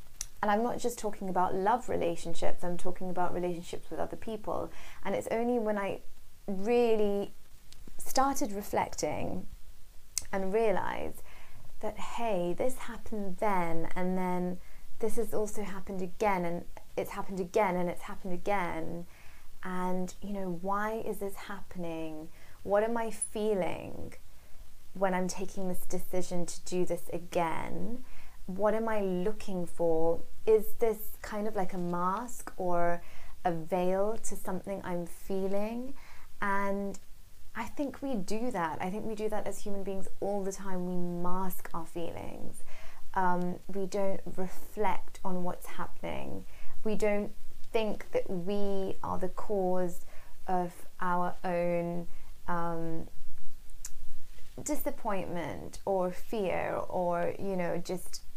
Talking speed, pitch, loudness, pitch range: 135 wpm, 185 Hz, -34 LUFS, 175-210 Hz